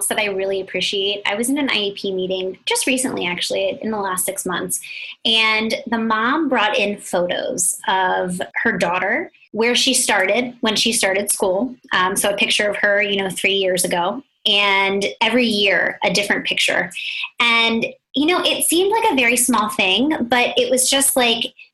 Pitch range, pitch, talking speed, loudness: 195-255 Hz, 220 Hz, 180 wpm, -17 LUFS